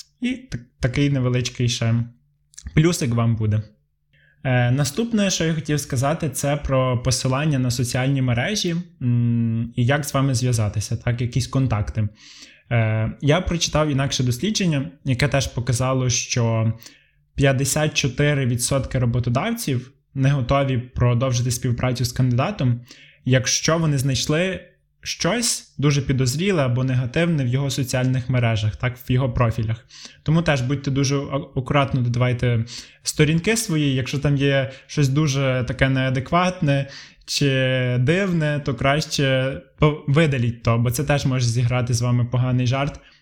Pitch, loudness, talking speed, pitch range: 135 Hz, -21 LUFS, 130 wpm, 125-145 Hz